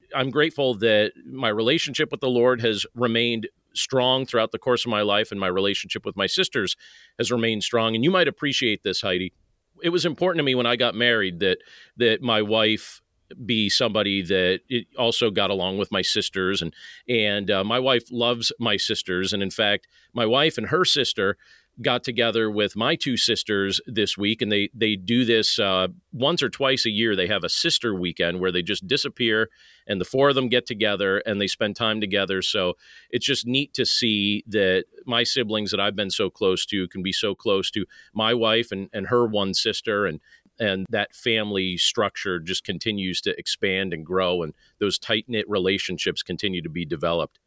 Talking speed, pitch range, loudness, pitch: 200 wpm, 100-120 Hz, -23 LUFS, 110 Hz